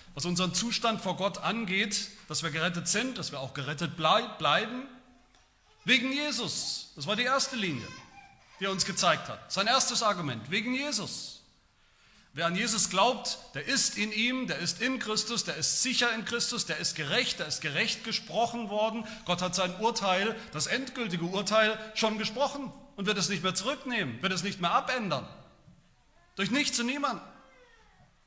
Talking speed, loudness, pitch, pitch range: 175 wpm, -29 LUFS, 215 Hz, 180-240 Hz